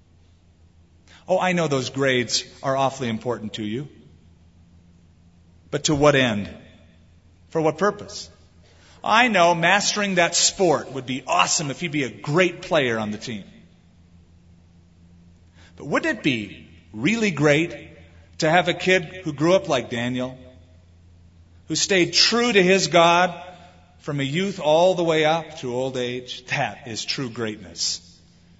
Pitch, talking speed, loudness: 125 Hz, 145 wpm, -21 LUFS